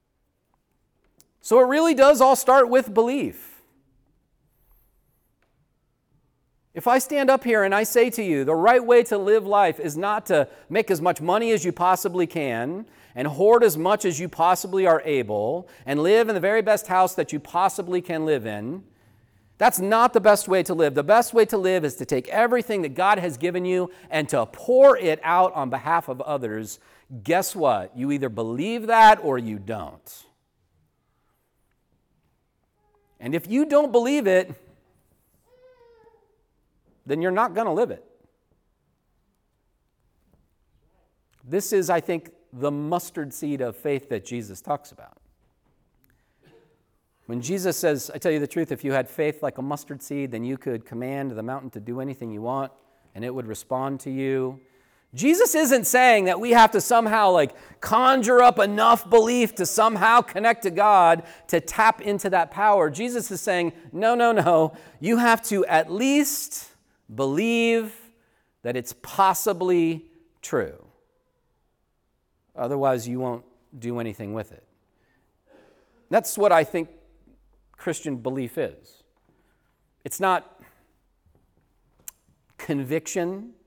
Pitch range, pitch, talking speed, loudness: 135-220 Hz, 175 Hz, 150 wpm, -21 LUFS